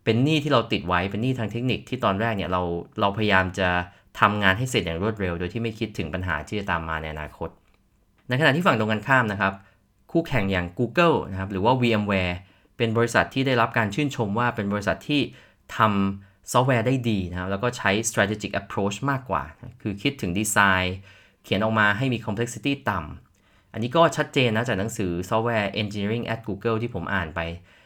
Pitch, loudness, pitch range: 105 Hz, -24 LUFS, 95-115 Hz